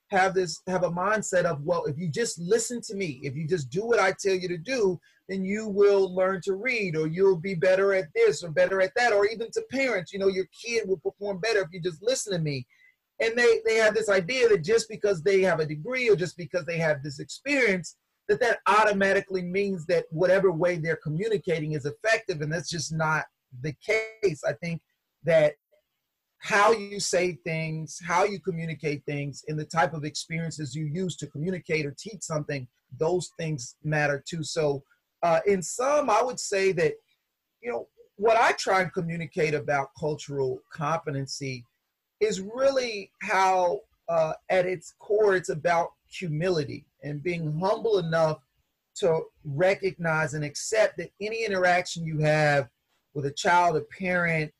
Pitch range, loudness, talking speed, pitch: 155-205 Hz, -26 LUFS, 180 wpm, 180 Hz